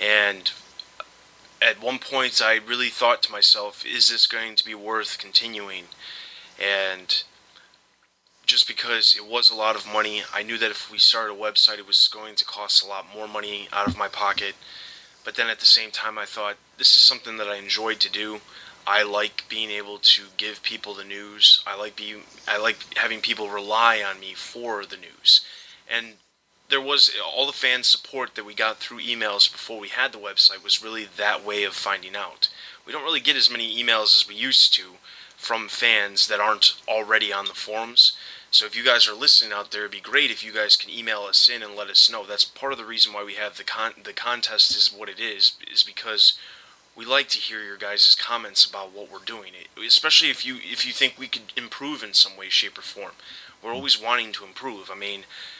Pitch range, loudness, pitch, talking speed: 100-115 Hz, -19 LUFS, 105 Hz, 215 wpm